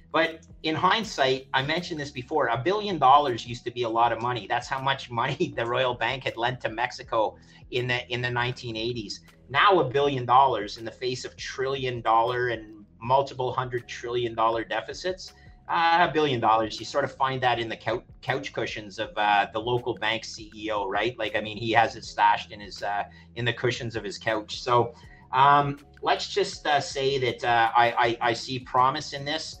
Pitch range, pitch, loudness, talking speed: 115-135 Hz, 120 Hz, -26 LUFS, 205 wpm